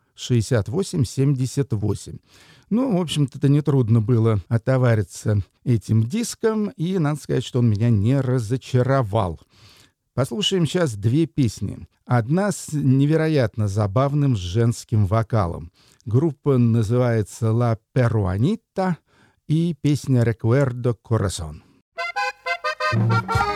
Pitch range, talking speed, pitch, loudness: 110-145 Hz, 90 wpm, 125 Hz, -21 LUFS